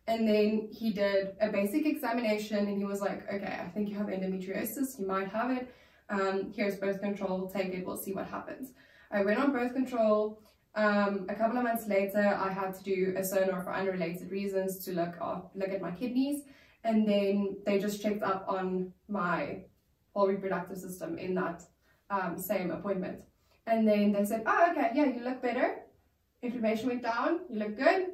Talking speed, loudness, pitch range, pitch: 190 wpm, -32 LUFS, 195-225 Hz, 205 Hz